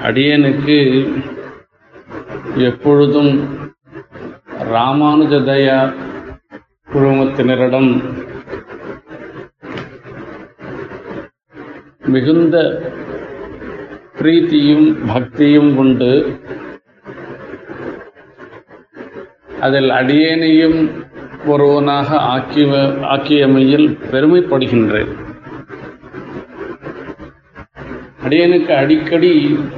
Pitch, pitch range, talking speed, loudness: 145 Hz, 135-155 Hz, 30 wpm, -12 LUFS